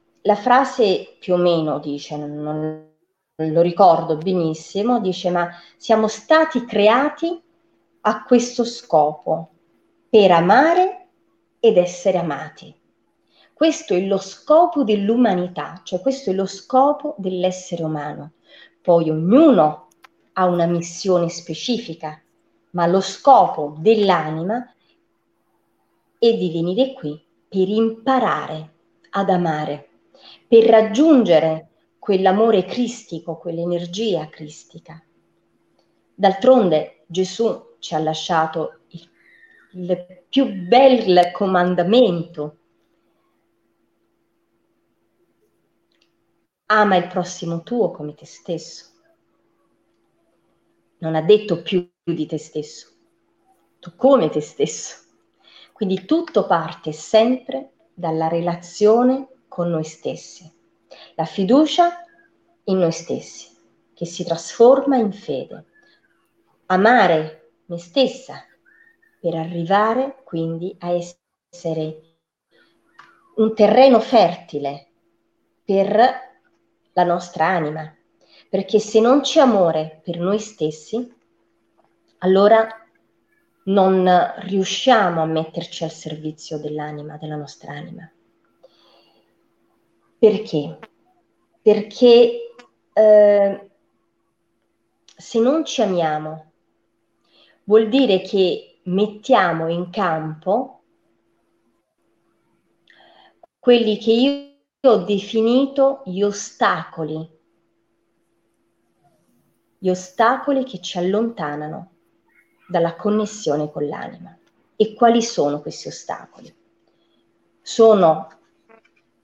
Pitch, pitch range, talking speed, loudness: 185 Hz, 165-235 Hz, 90 wpm, -18 LUFS